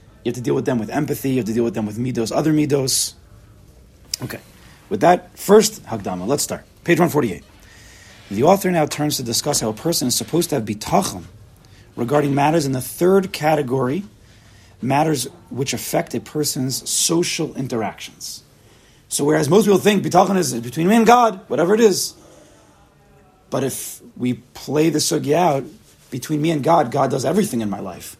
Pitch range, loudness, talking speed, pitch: 115-165 Hz, -19 LUFS, 180 wpm, 140 Hz